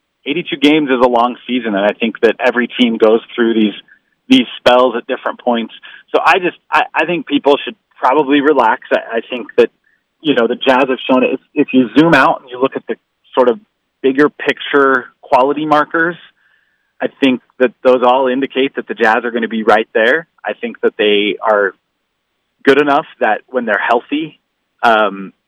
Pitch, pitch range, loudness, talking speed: 130 Hz, 120-145 Hz, -13 LUFS, 200 wpm